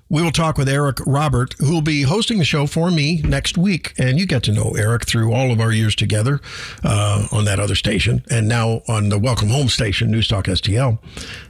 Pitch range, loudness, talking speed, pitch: 110-145 Hz, -18 LUFS, 220 wpm, 125 Hz